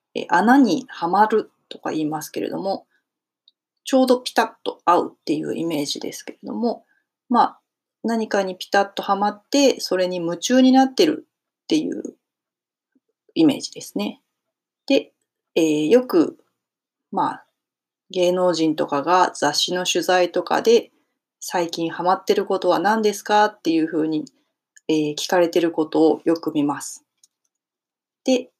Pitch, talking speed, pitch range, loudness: 200 Hz, 275 characters per minute, 170-260 Hz, -20 LUFS